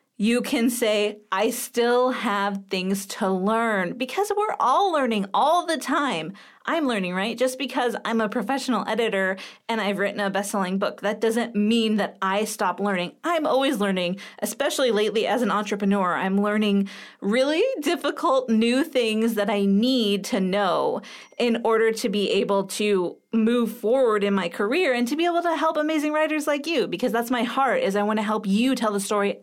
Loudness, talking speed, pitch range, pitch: -23 LUFS, 185 wpm, 200-260 Hz, 225 Hz